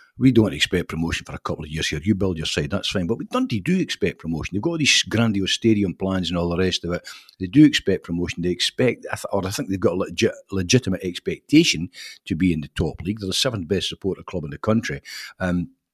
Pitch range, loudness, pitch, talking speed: 85-110 Hz, -22 LUFS, 95 Hz, 250 wpm